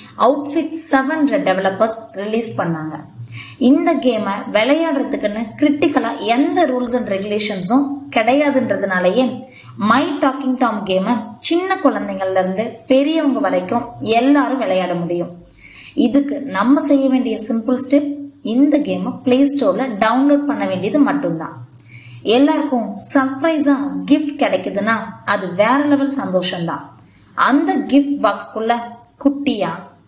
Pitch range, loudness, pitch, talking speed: 205-285 Hz, -17 LUFS, 255 Hz, 105 wpm